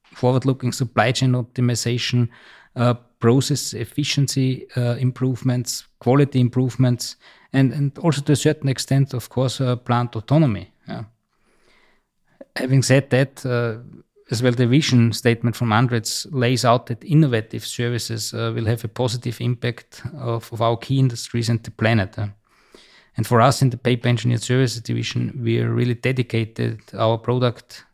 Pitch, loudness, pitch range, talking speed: 120 Hz, -21 LUFS, 115-130 Hz, 145 wpm